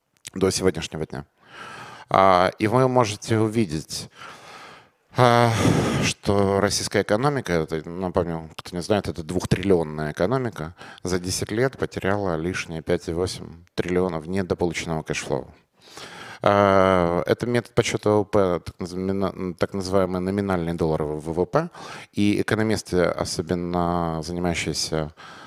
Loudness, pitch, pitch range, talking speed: -23 LUFS, 95 Hz, 85-105 Hz, 95 wpm